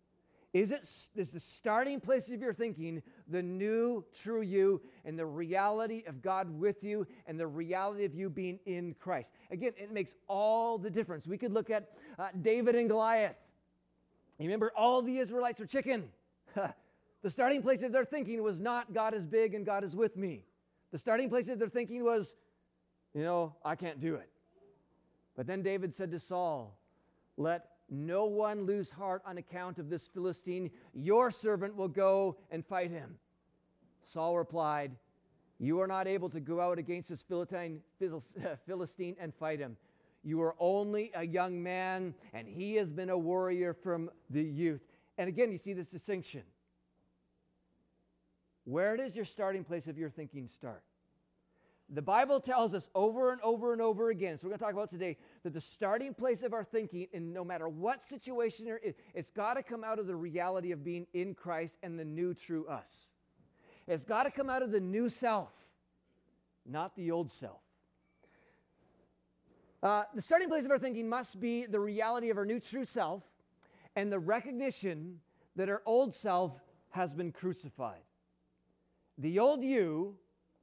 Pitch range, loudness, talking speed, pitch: 165-220 Hz, -36 LUFS, 175 wpm, 185 Hz